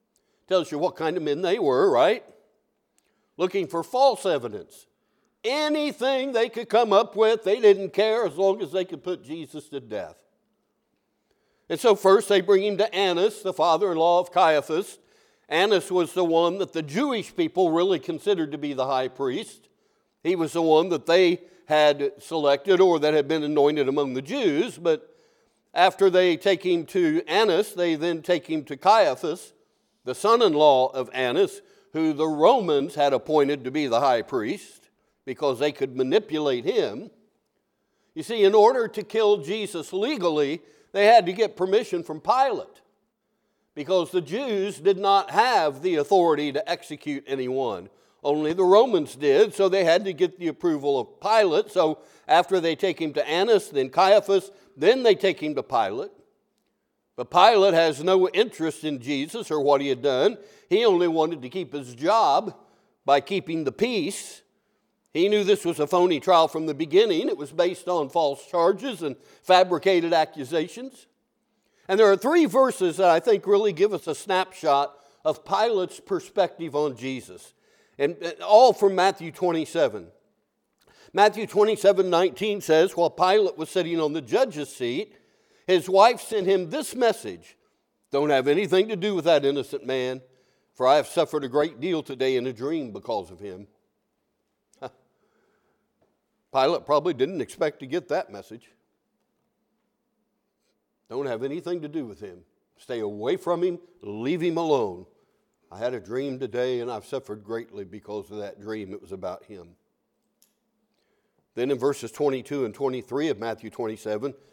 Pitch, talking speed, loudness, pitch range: 180 Hz, 165 wpm, -23 LUFS, 150-225 Hz